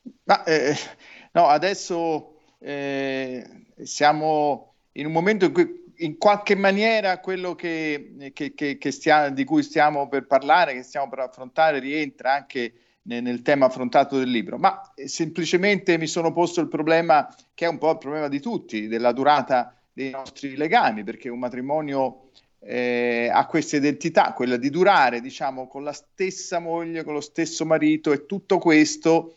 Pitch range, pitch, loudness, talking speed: 135-170 Hz, 150 Hz, -22 LUFS, 165 wpm